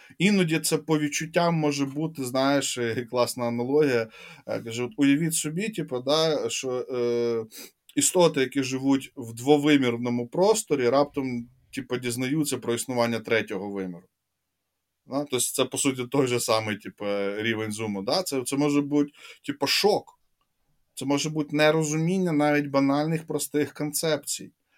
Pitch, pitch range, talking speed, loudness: 135 Hz, 120-150 Hz, 135 wpm, -25 LUFS